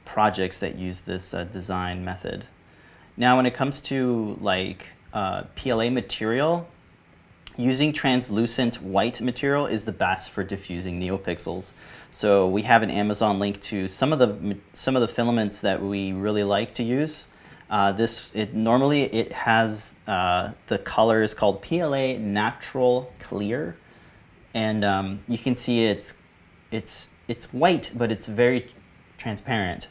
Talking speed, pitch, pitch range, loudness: 145 wpm, 110 Hz, 95-125 Hz, -24 LUFS